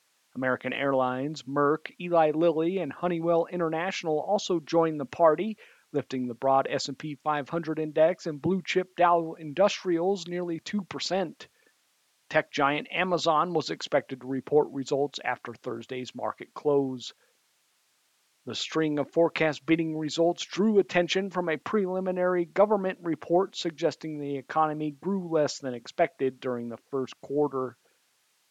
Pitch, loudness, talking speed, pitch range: 160 Hz, -28 LUFS, 130 wpm, 140-175 Hz